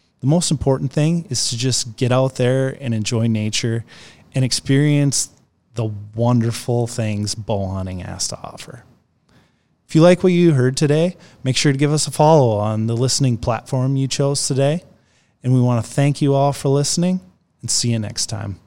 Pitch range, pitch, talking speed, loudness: 115-145 Hz, 130 Hz, 185 wpm, -18 LUFS